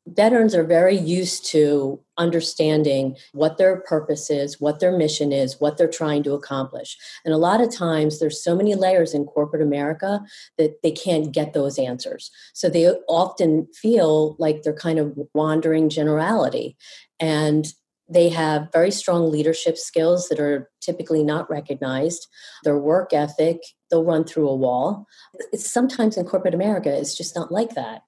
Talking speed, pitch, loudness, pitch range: 165 wpm, 160 Hz, -21 LUFS, 150-175 Hz